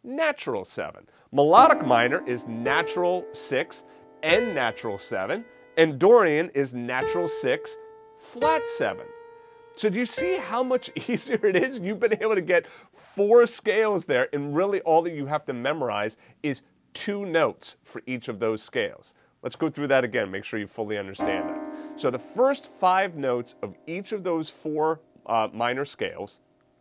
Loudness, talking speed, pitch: -25 LUFS, 165 wpm, 185 Hz